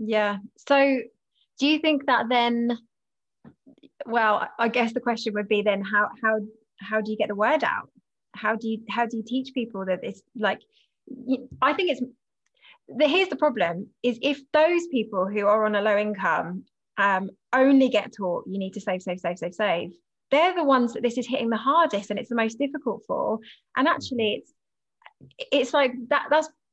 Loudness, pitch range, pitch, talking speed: -24 LUFS, 210-275 Hz, 235 Hz, 195 wpm